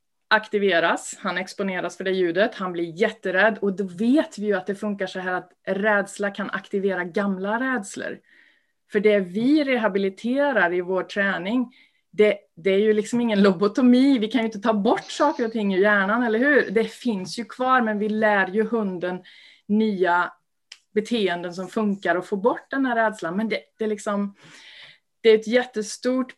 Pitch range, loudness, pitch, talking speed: 195-225 Hz, -22 LUFS, 210 Hz, 180 wpm